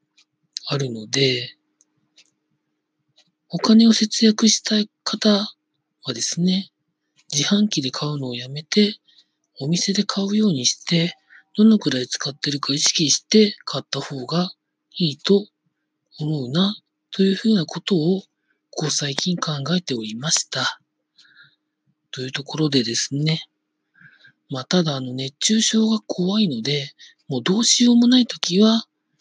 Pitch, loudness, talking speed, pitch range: 165 Hz, -20 LUFS, 245 characters per minute, 145-210 Hz